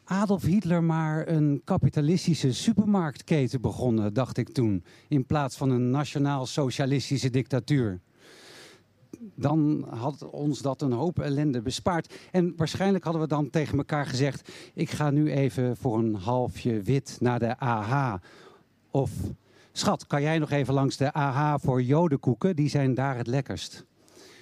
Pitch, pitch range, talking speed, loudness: 140 Hz, 125-155 Hz, 145 wpm, -27 LUFS